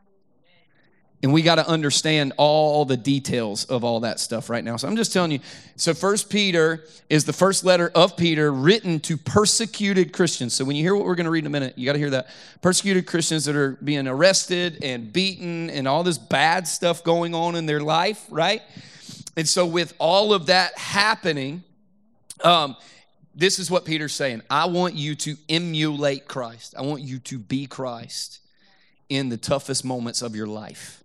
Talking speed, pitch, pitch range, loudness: 195 wpm, 160 Hz, 140-180 Hz, -21 LUFS